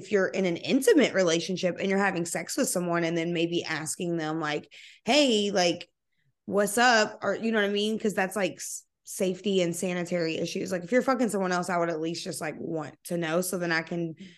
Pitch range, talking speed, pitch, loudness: 170-200 Hz, 225 wpm, 180 Hz, -27 LUFS